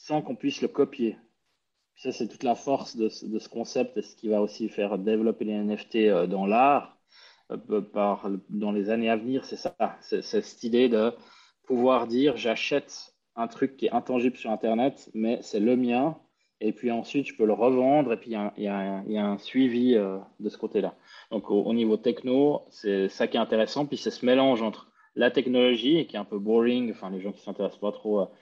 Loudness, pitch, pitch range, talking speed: -27 LUFS, 115 Hz, 105-125 Hz, 220 wpm